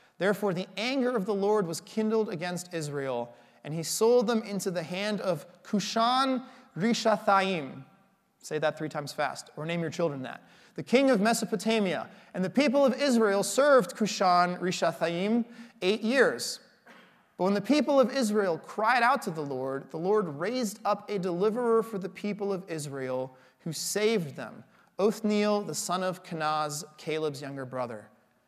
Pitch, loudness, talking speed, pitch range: 195 Hz, -28 LUFS, 160 wpm, 160-220 Hz